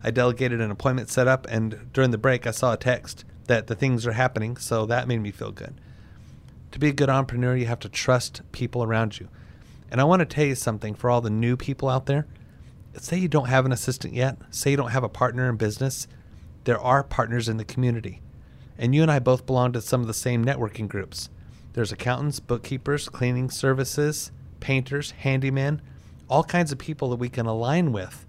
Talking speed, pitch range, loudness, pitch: 215 wpm, 115-135 Hz, -24 LUFS, 125 Hz